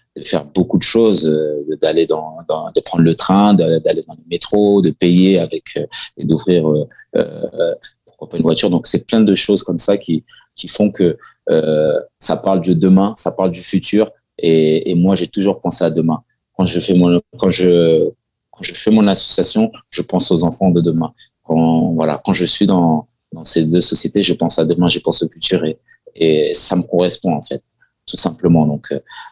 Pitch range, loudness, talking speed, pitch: 80-100 Hz, -15 LUFS, 210 wpm, 90 Hz